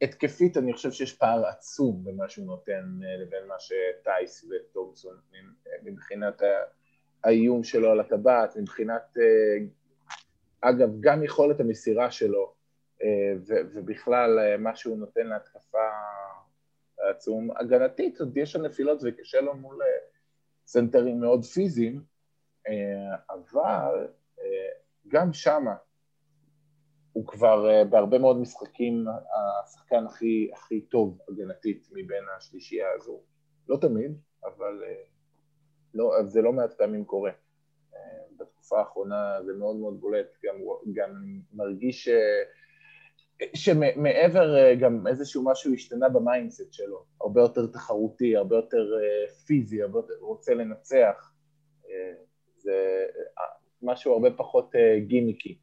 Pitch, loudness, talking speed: 150 Hz, -26 LUFS, 105 wpm